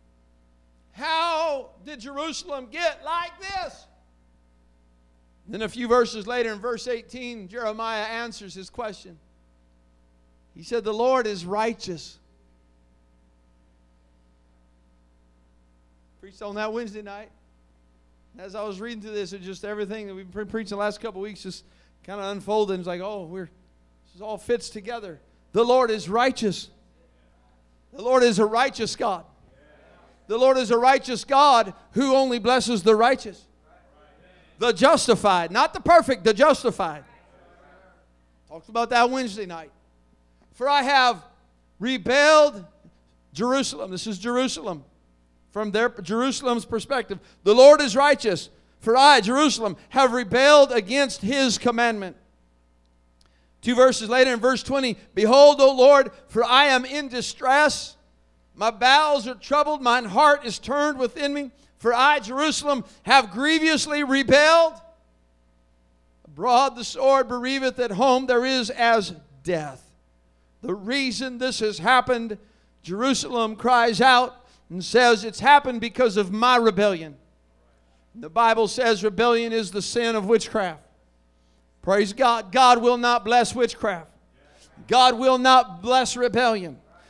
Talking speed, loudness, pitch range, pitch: 135 wpm, -20 LUFS, 160-255 Hz, 225 Hz